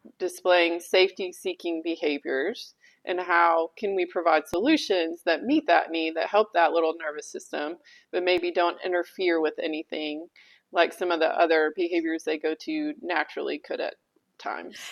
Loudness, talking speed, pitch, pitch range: -26 LUFS, 155 wpm, 170 Hz, 165-185 Hz